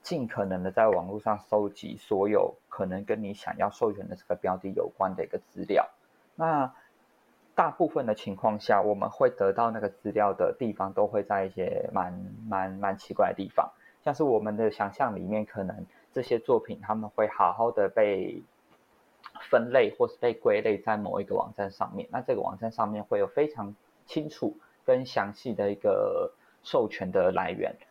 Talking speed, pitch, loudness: 270 characters per minute, 325 Hz, -29 LUFS